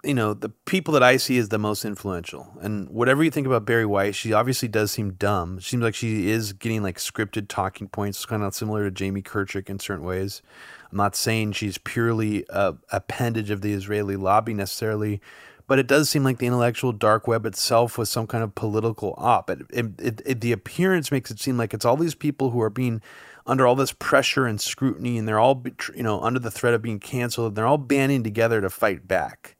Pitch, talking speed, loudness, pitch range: 115 Hz, 230 wpm, -23 LUFS, 105-125 Hz